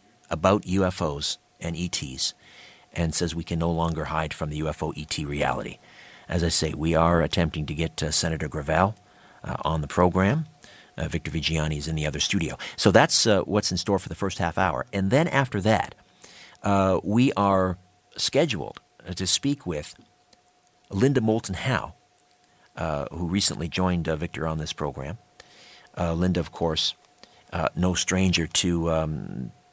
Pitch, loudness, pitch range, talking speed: 85 Hz, -25 LUFS, 80-95 Hz, 165 wpm